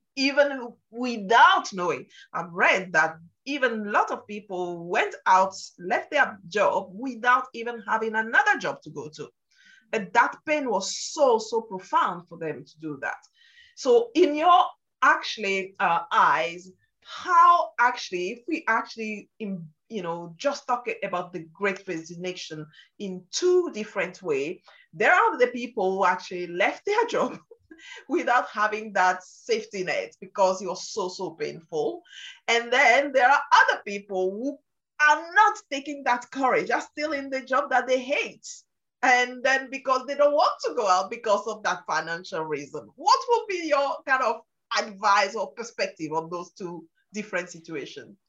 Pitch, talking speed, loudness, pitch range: 225 Hz, 160 wpm, -24 LUFS, 185-285 Hz